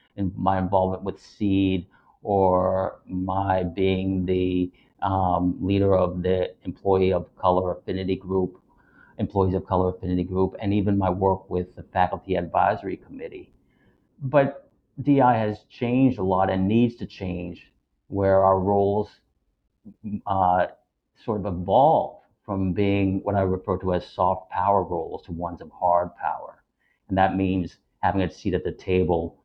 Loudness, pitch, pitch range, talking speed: -24 LUFS, 95 Hz, 90-100 Hz, 150 wpm